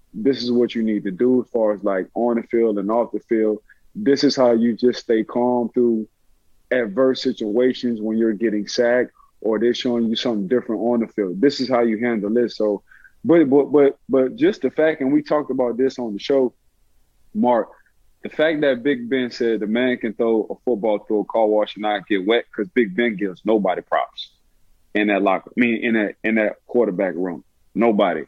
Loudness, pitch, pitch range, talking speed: -20 LUFS, 120 Hz, 110-125 Hz, 215 wpm